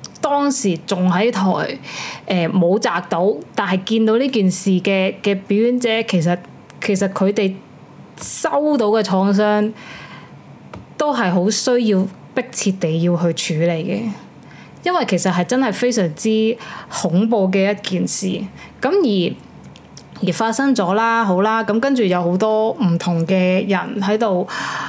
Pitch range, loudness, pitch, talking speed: 185-225 Hz, -18 LUFS, 200 Hz, 200 characters per minute